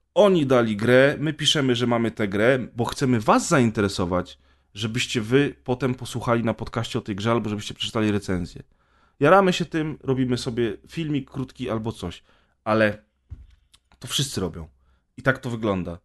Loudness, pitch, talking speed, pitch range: -23 LUFS, 120 Hz, 160 wpm, 100-130 Hz